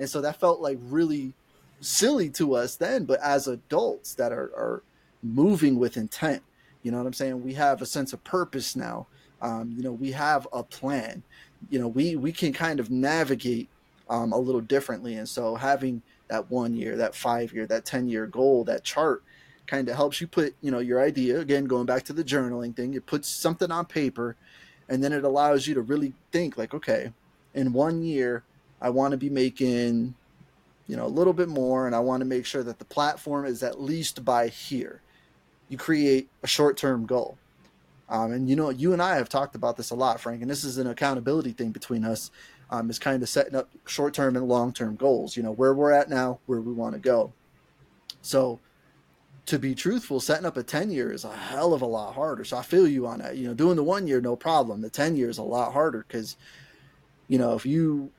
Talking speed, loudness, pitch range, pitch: 225 wpm, -26 LUFS, 120-145 Hz, 130 Hz